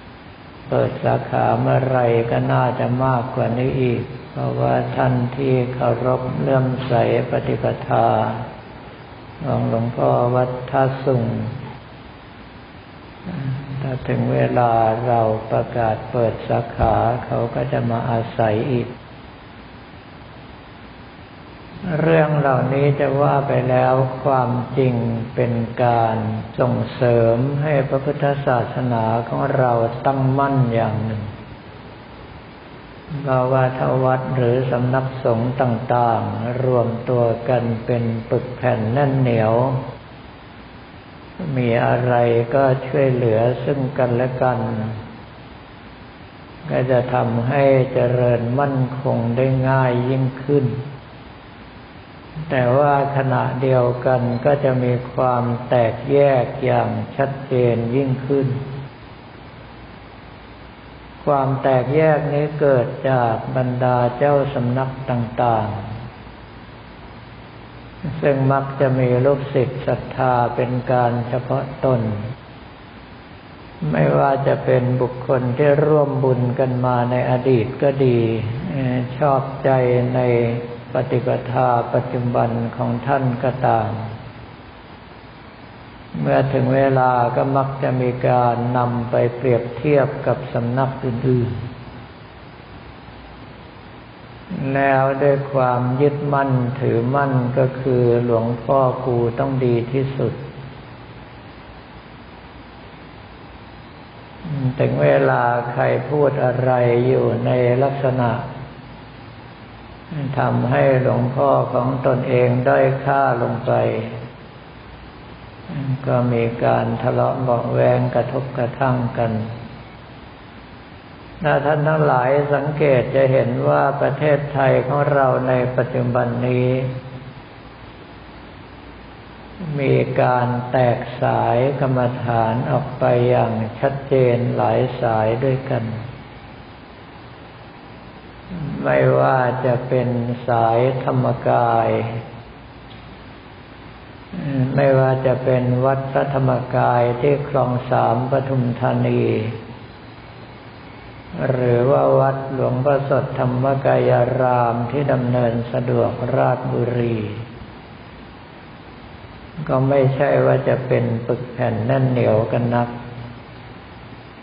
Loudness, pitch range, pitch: -19 LUFS, 120-135 Hz, 125 Hz